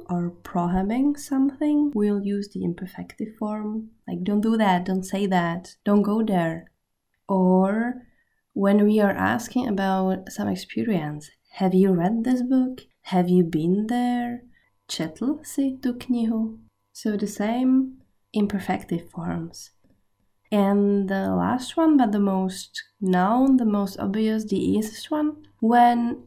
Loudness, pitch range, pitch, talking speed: -23 LUFS, 180-240 Hz, 205 Hz, 135 wpm